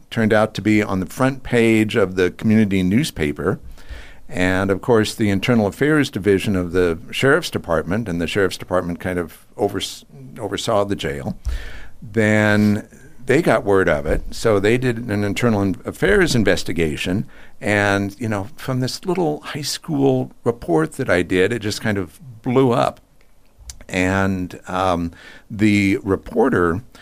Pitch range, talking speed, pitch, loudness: 95-120 Hz, 155 wpm, 105 Hz, -19 LUFS